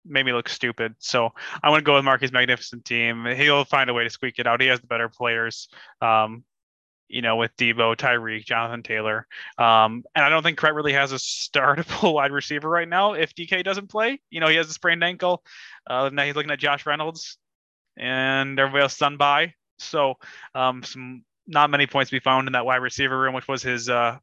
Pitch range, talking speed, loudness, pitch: 120-150 Hz, 220 wpm, -21 LUFS, 130 Hz